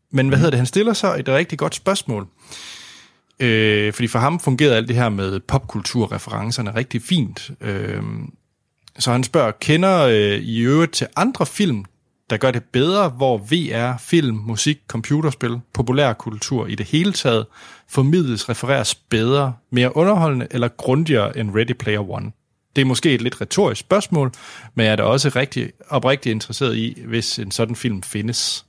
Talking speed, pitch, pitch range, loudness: 165 wpm, 125 Hz, 115-140 Hz, -19 LUFS